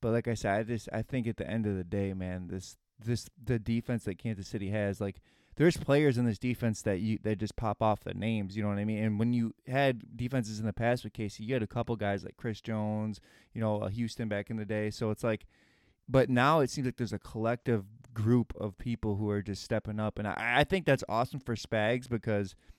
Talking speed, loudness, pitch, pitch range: 255 wpm, -32 LUFS, 110 Hz, 105-120 Hz